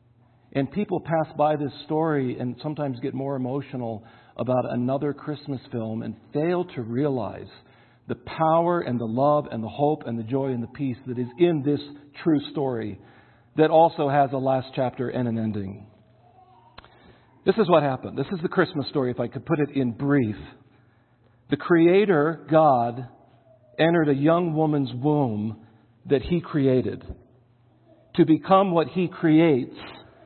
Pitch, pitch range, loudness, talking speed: 135 Hz, 120-155 Hz, -24 LUFS, 160 wpm